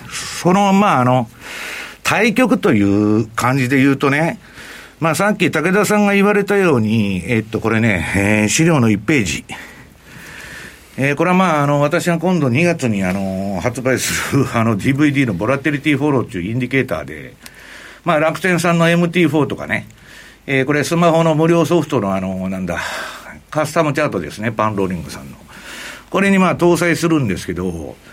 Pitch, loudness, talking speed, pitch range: 135 Hz, -16 LUFS, 320 characters per minute, 110-170 Hz